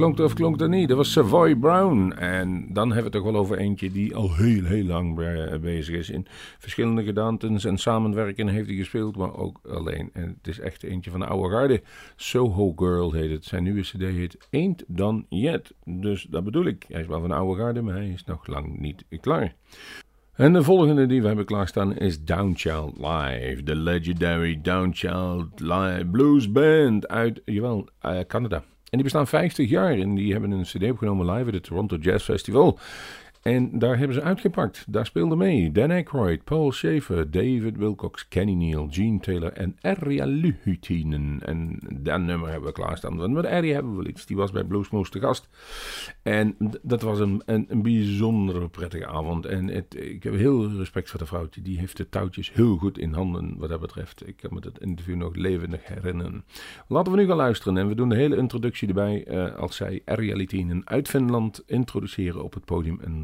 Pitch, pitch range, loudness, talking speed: 100 Hz, 90-115 Hz, -25 LUFS, 200 wpm